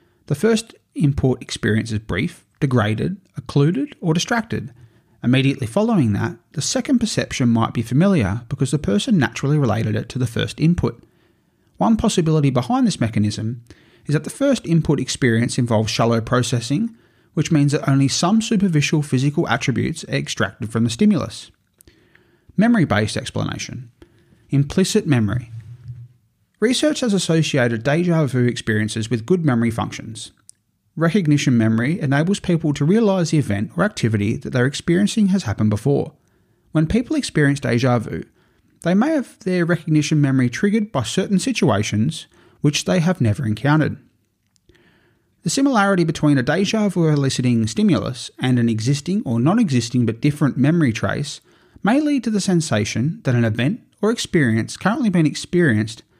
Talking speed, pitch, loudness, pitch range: 145 wpm, 140 Hz, -19 LUFS, 115-175 Hz